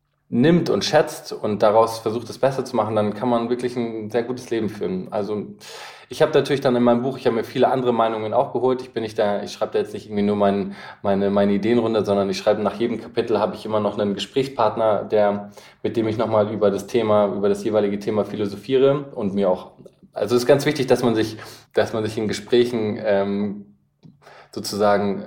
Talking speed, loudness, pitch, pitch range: 225 wpm, -21 LUFS, 110 Hz, 100-120 Hz